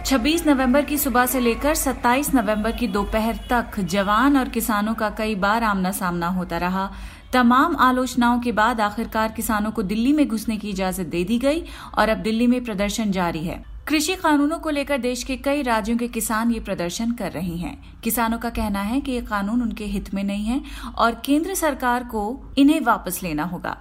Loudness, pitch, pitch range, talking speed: -21 LUFS, 230 Hz, 205-260 Hz, 195 wpm